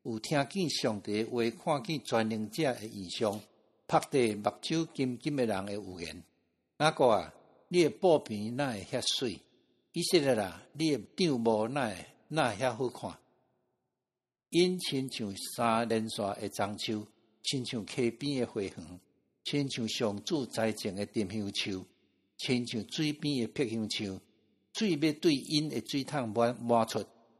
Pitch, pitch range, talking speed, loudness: 115 Hz, 105-140 Hz, 205 characters per minute, -32 LUFS